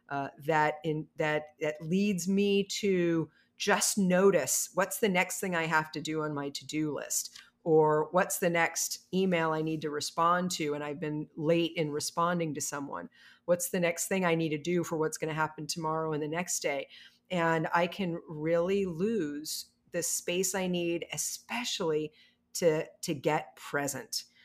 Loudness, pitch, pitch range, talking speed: -31 LUFS, 165 Hz, 155-180 Hz, 175 wpm